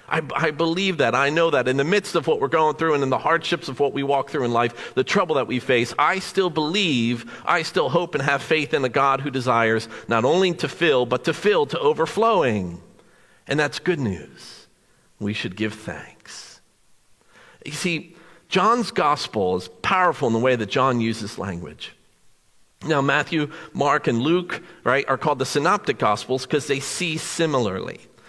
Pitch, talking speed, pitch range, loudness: 145 Hz, 190 wpm, 125-165 Hz, -21 LUFS